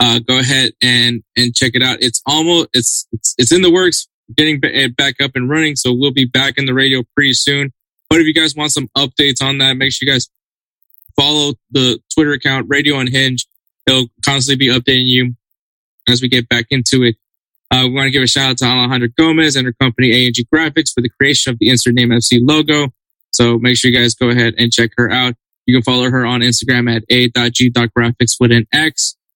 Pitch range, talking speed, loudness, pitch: 120-140 Hz, 225 wpm, -12 LUFS, 130 Hz